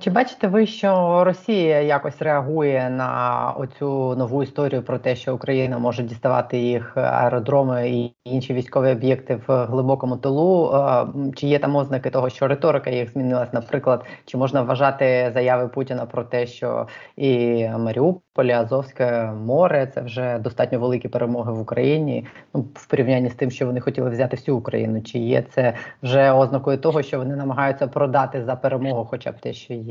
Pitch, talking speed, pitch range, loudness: 130 Hz, 170 wpm, 125-140 Hz, -21 LUFS